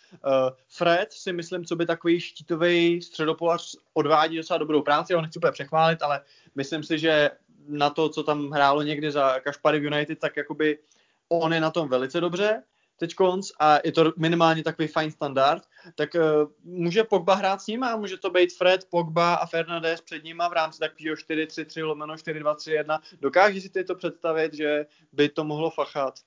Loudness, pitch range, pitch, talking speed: -25 LUFS, 150-170 Hz, 160 Hz, 185 wpm